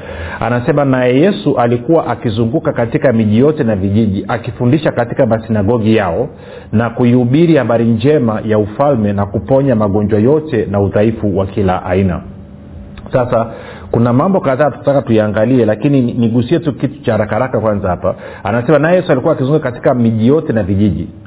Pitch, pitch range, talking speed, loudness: 115 Hz, 105-135 Hz, 150 wpm, -13 LUFS